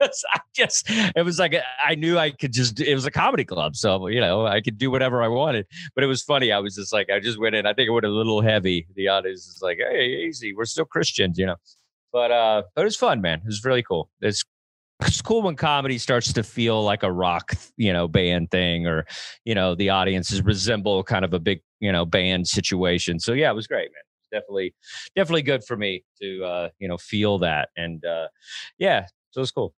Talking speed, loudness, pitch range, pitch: 240 wpm, -22 LUFS, 95-140 Hz, 110 Hz